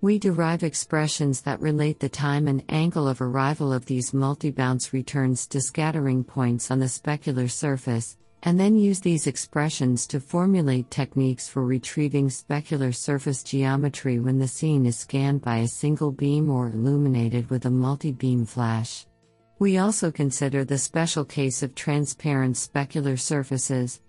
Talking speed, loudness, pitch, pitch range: 150 wpm, -24 LUFS, 135 Hz, 130-150 Hz